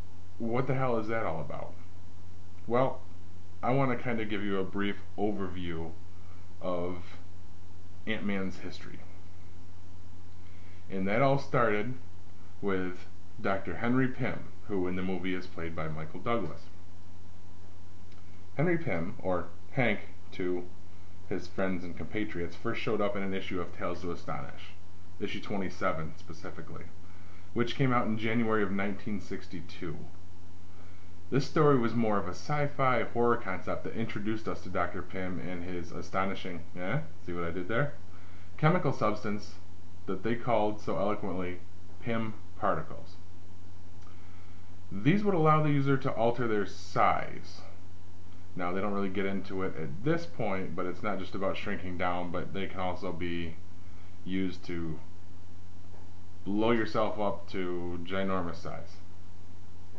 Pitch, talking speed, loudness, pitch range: 90 Hz, 140 wpm, -33 LUFS, 90-100 Hz